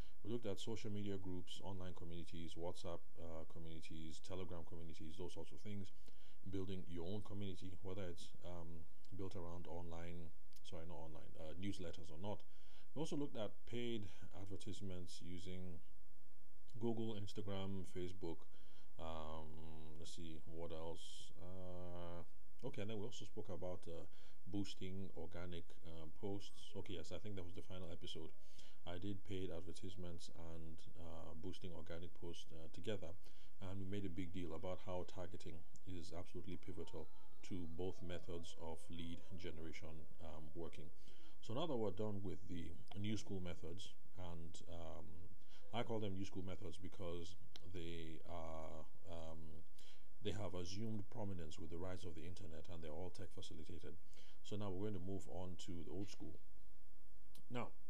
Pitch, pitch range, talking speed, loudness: 90 Hz, 85-100 Hz, 155 wpm, -52 LUFS